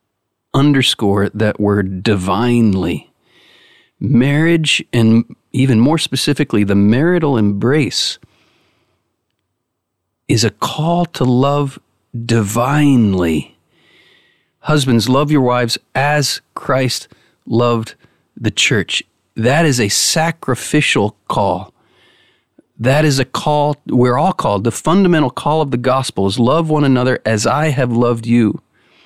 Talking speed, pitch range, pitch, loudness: 110 wpm, 110-145 Hz, 120 Hz, -14 LUFS